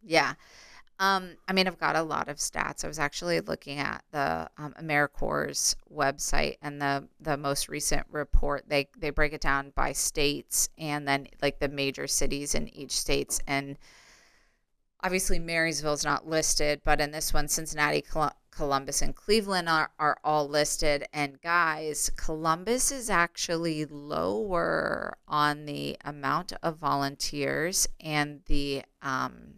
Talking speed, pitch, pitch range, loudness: 150 wpm, 150 Hz, 140-160 Hz, -29 LUFS